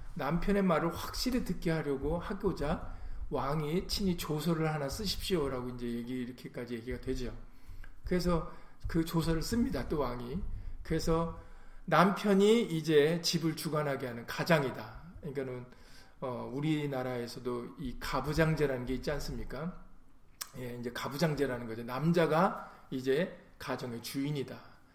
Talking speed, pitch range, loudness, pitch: 310 characters per minute, 125-170 Hz, -33 LUFS, 145 Hz